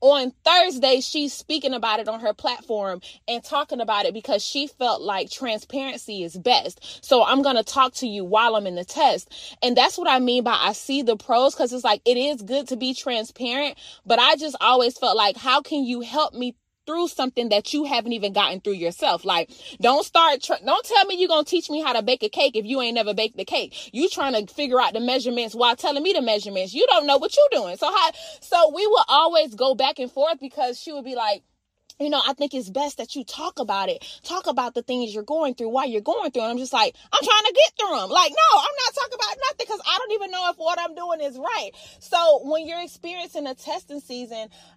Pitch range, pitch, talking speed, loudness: 235-315 Hz, 270 Hz, 245 wpm, -21 LUFS